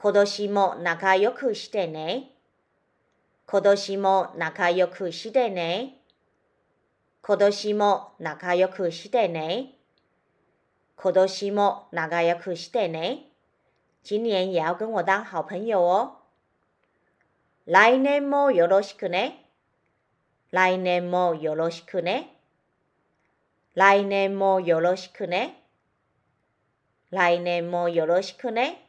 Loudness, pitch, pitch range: -24 LUFS, 185 Hz, 170-205 Hz